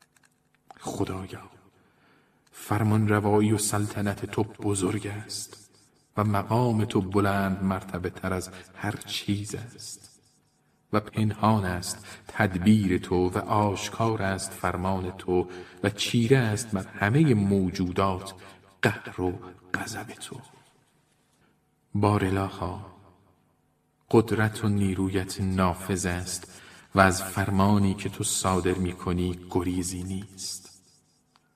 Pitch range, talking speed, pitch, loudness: 95-105 Hz, 105 wpm, 100 Hz, -27 LUFS